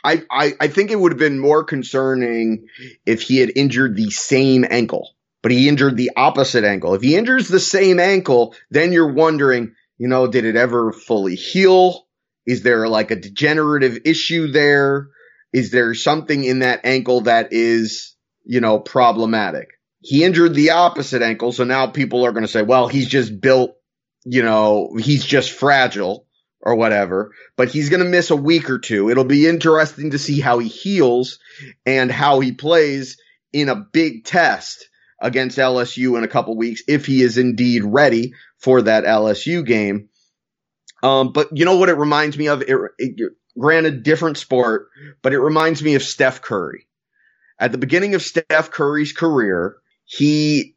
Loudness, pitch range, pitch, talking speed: -16 LUFS, 120-155 Hz, 130 Hz, 175 wpm